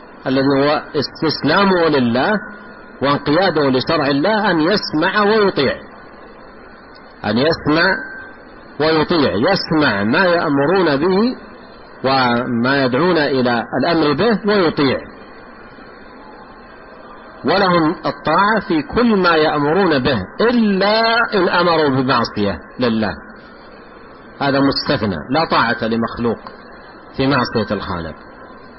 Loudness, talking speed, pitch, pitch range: -16 LUFS, 90 wpm, 145 Hz, 125-190 Hz